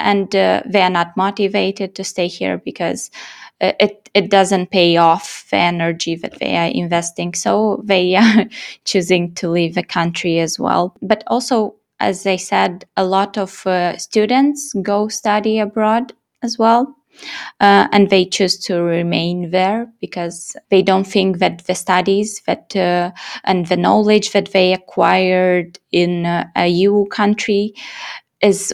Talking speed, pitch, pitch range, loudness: 155 wpm, 190 Hz, 180-210 Hz, -16 LUFS